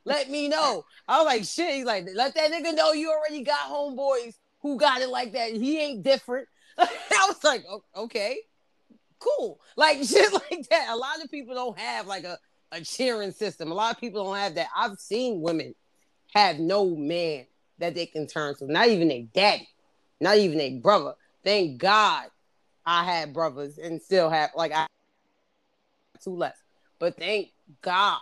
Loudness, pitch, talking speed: -25 LUFS, 230 Hz, 185 wpm